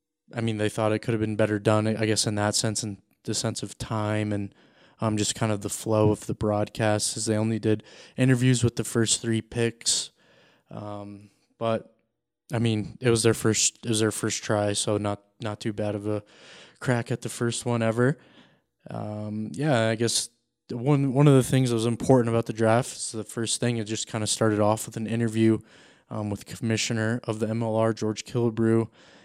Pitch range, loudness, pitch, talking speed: 105-115 Hz, -26 LUFS, 110 Hz, 210 wpm